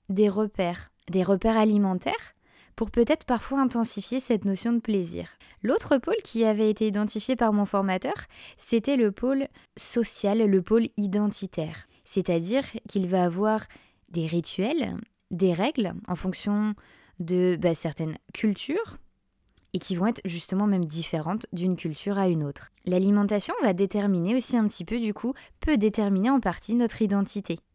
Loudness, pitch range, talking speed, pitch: -26 LUFS, 185-230 Hz, 150 wpm, 205 Hz